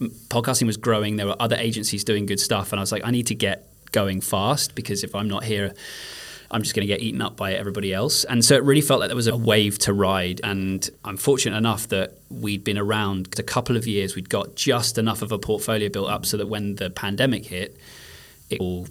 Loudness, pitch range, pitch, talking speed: -23 LUFS, 100-115 Hz, 105 Hz, 240 wpm